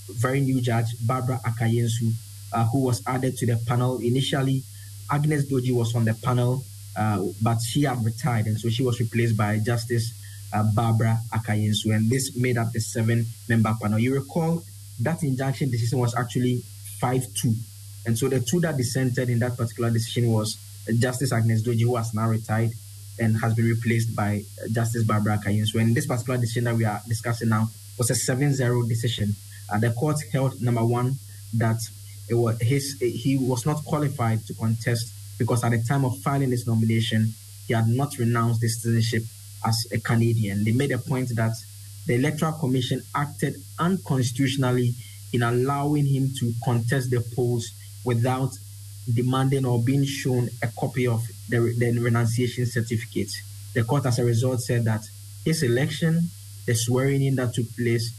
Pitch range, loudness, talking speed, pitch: 110-130 Hz, -25 LUFS, 175 wpm, 115 Hz